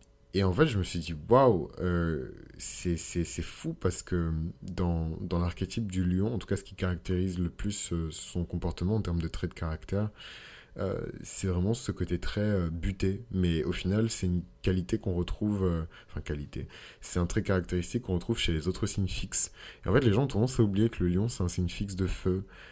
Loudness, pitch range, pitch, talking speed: -30 LUFS, 85-100 Hz, 90 Hz, 220 wpm